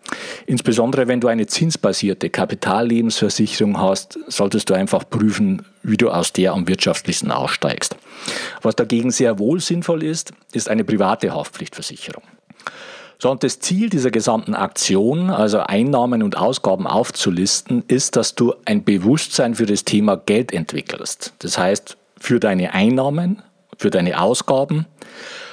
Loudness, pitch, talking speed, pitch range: -18 LUFS, 125 Hz, 135 wpm, 110-180 Hz